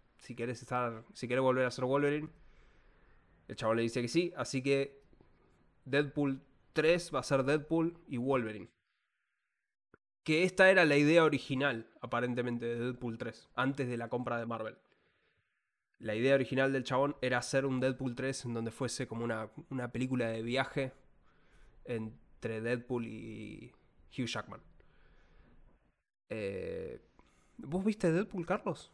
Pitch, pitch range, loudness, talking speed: 130 Hz, 120-145 Hz, -34 LUFS, 145 wpm